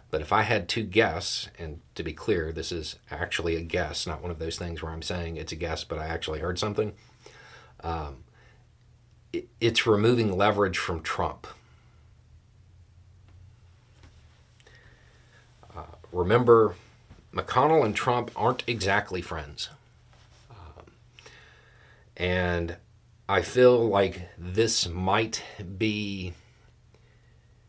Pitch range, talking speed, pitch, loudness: 90-115 Hz, 115 wpm, 100 Hz, -27 LUFS